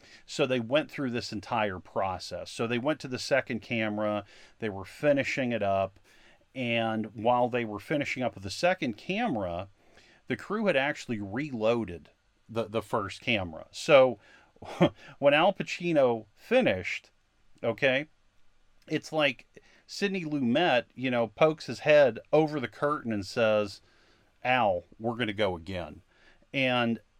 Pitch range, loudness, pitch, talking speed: 105-140 Hz, -29 LUFS, 115 Hz, 145 wpm